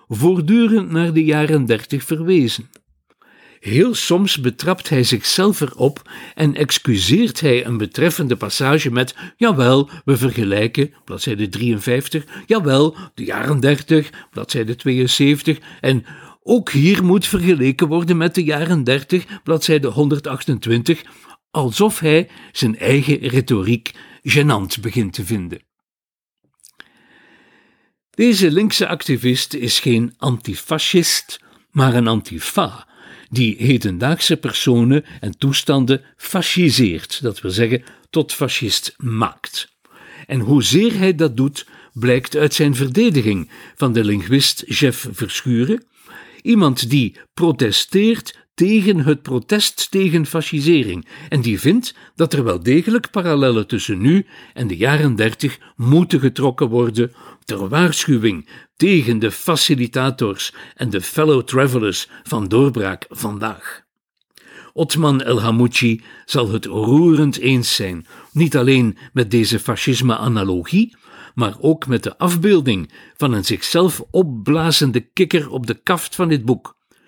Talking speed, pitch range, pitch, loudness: 120 wpm, 120-165 Hz, 140 Hz, -17 LUFS